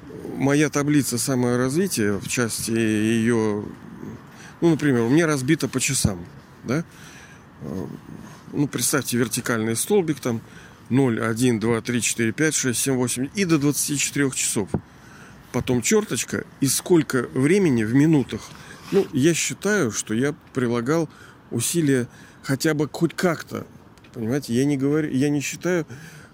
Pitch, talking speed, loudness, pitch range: 135 Hz, 130 wpm, -22 LUFS, 120-150 Hz